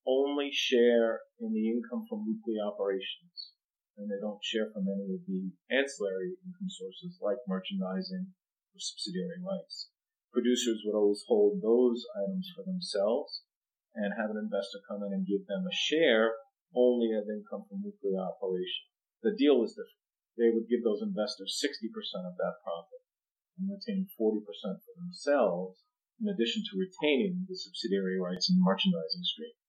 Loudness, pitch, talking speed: -32 LUFS, 135 Hz, 155 wpm